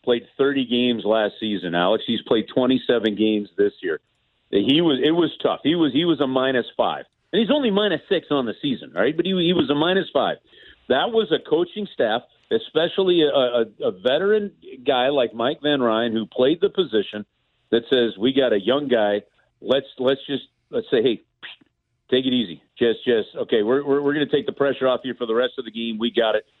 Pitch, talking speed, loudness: 135 Hz, 220 wpm, -21 LUFS